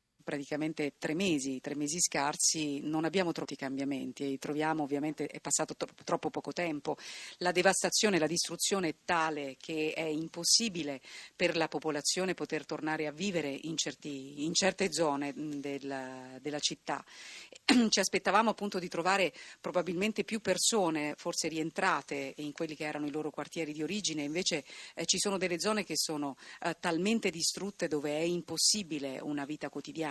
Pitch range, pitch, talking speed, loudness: 150-180 Hz, 155 Hz, 150 wpm, -32 LUFS